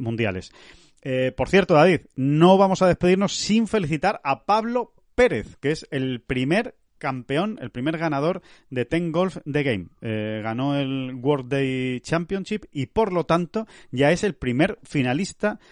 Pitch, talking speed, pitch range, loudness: 155 Hz, 160 wpm, 130-190 Hz, -23 LUFS